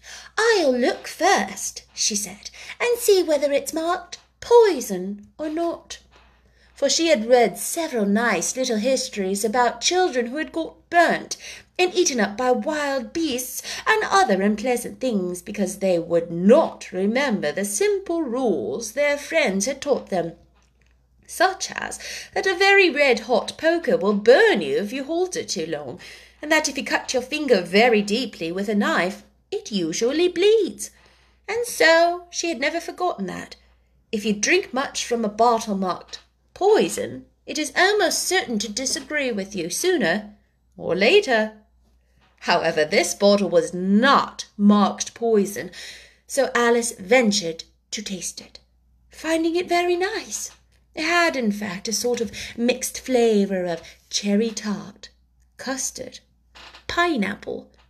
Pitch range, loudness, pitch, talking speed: 205-330 Hz, -21 LUFS, 245 Hz, 145 wpm